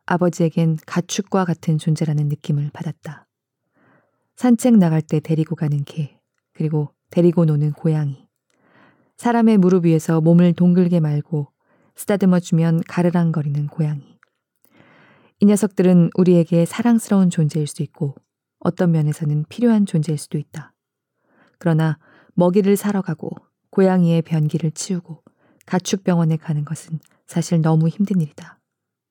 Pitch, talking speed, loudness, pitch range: 165 Hz, 305 characters per minute, -19 LUFS, 155-180 Hz